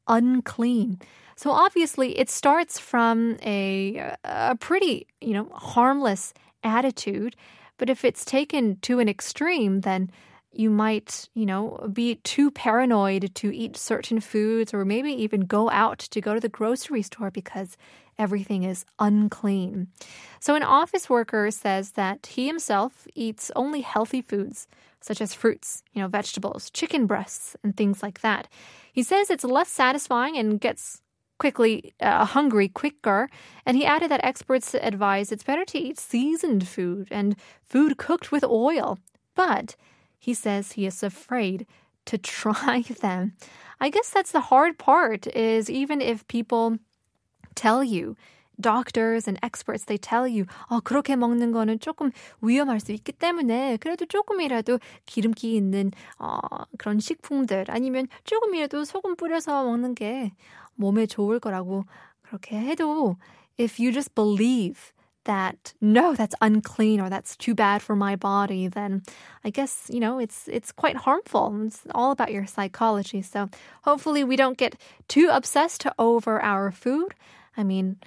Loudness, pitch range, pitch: -25 LUFS, 205-265 Hz, 230 Hz